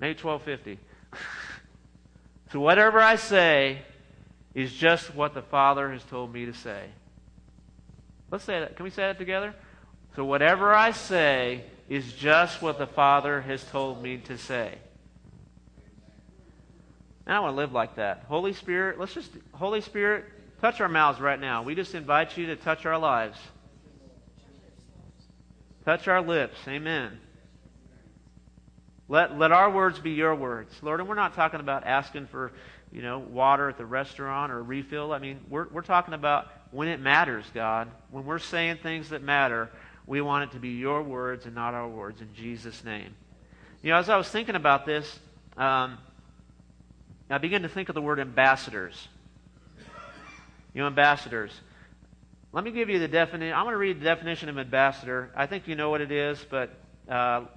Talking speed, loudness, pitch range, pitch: 175 wpm, -26 LUFS, 120-160 Hz, 140 Hz